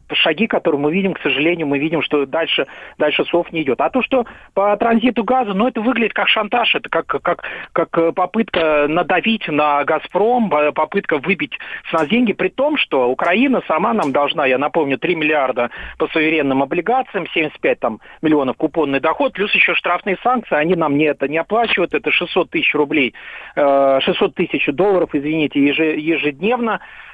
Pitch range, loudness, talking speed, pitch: 150-210 Hz, -17 LUFS, 170 wpm, 165 Hz